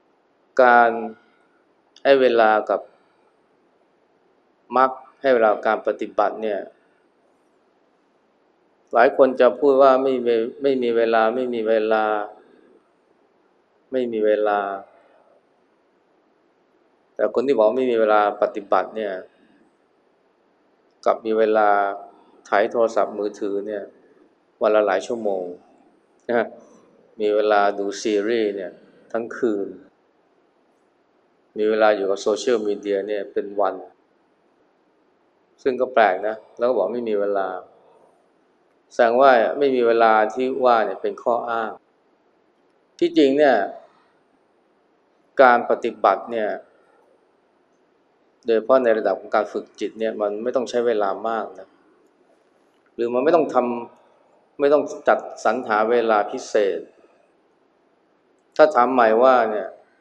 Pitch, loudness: 120 Hz, -20 LUFS